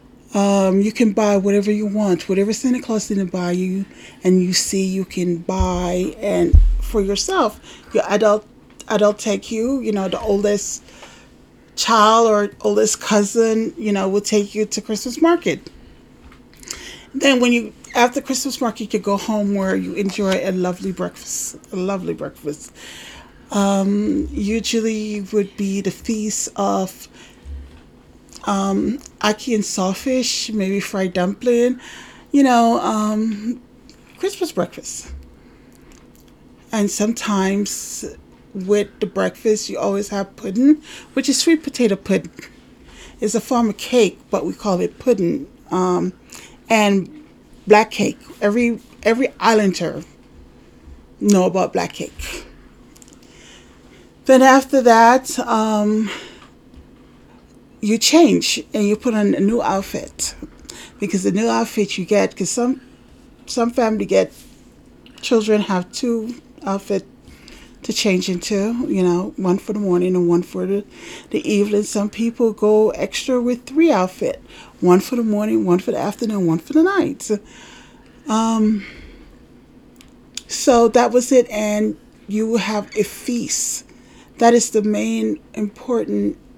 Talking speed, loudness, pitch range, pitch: 135 wpm, -18 LUFS, 195-240 Hz, 210 Hz